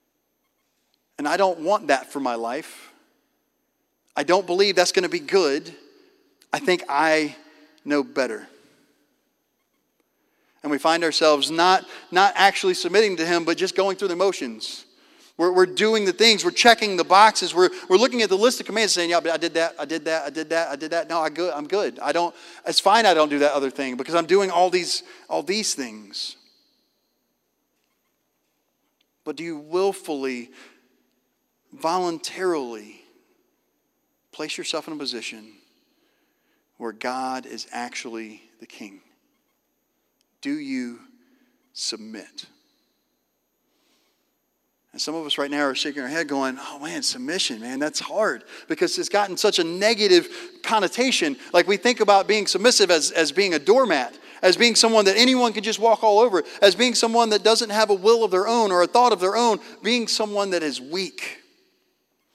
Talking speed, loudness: 170 wpm, -21 LUFS